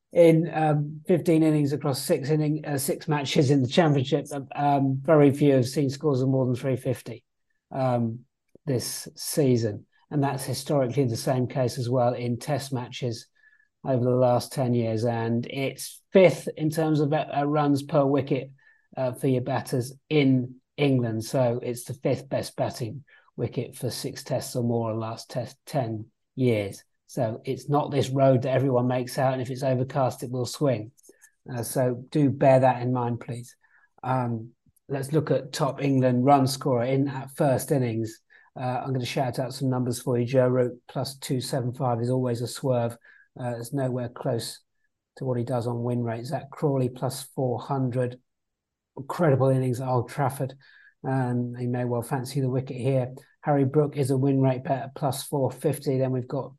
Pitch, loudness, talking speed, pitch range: 130 Hz, -26 LUFS, 180 wpm, 125-140 Hz